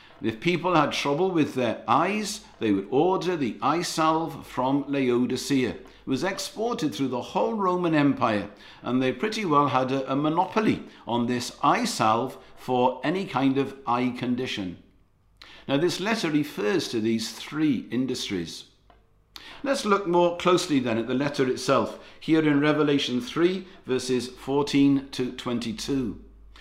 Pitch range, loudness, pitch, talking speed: 125-175 Hz, -25 LUFS, 140 Hz, 145 wpm